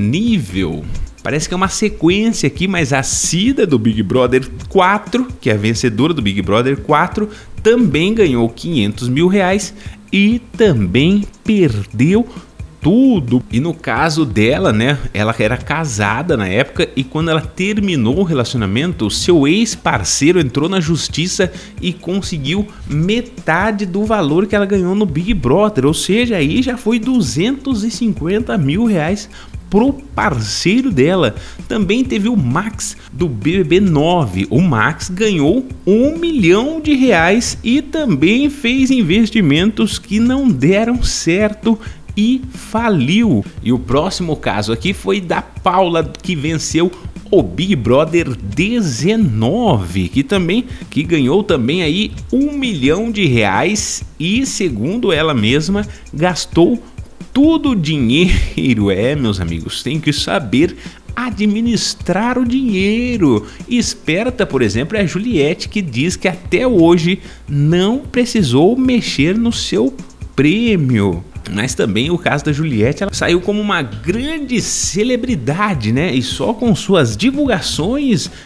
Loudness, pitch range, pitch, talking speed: -15 LUFS, 140-220 Hz, 185 Hz, 135 wpm